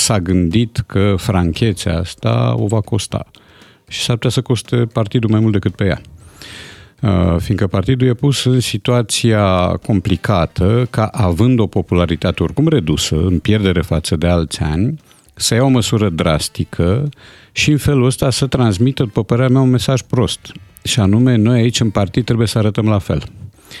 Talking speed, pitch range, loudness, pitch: 170 wpm, 95-120 Hz, -15 LUFS, 110 Hz